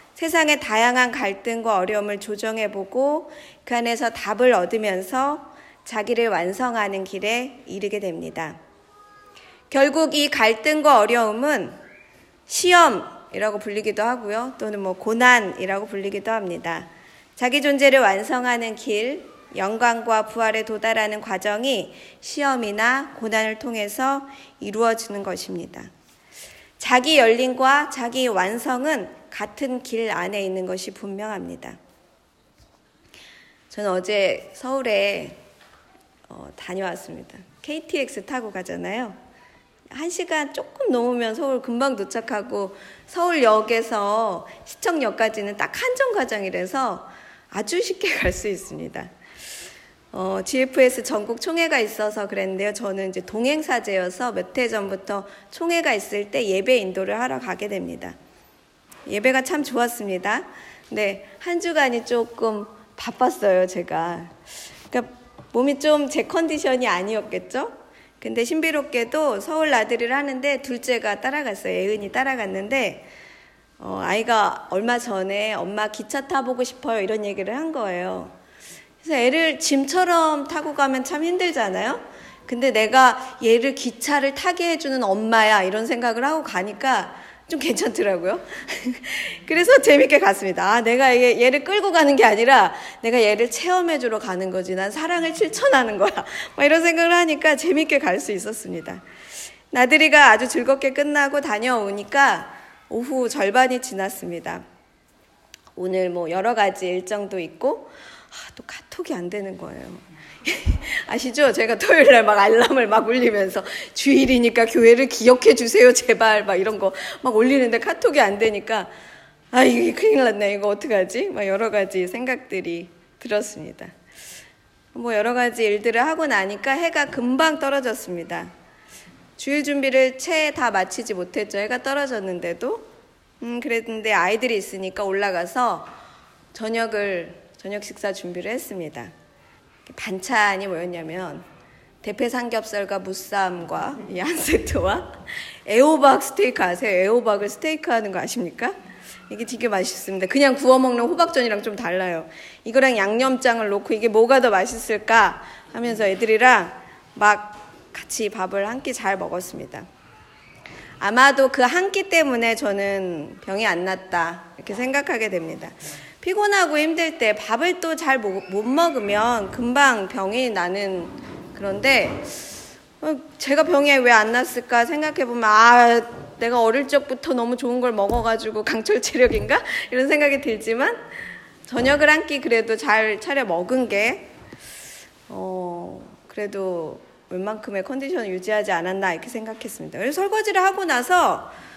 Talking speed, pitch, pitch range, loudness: 295 characters per minute, 235 Hz, 205-275 Hz, -20 LUFS